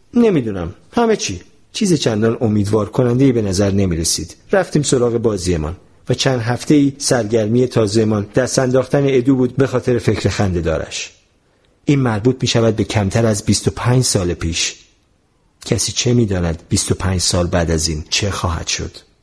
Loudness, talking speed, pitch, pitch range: -16 LUFS, 160 wpm, 115 Hz, 100-130 Hz